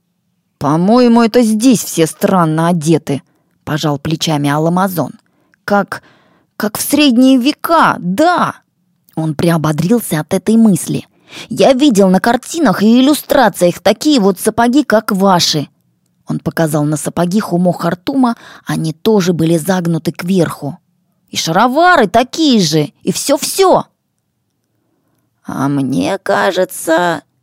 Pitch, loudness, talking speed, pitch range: 180 Hz, -12 LUFS, 110 wpm, 160-235 Hz